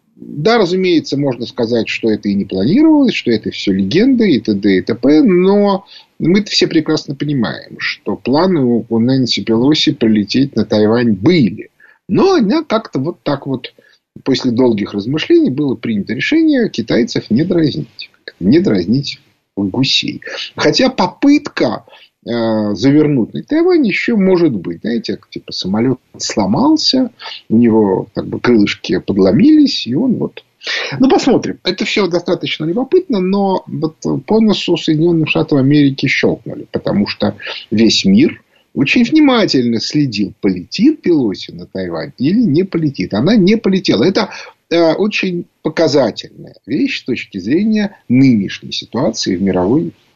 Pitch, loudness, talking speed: 160 Hz, -13 LUFS, 135 wpm